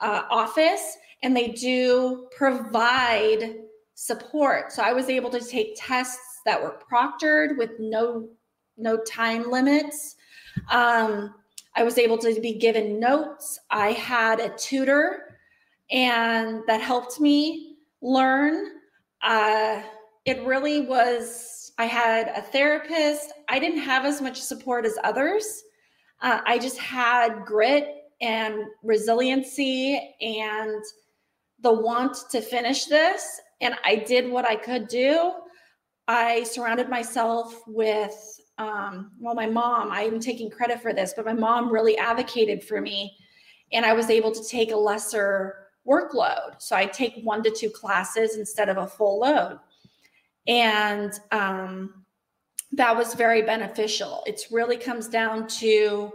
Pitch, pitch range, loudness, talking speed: 230 Hz, 220-255 Hz, -24 LUFS, 135 wpm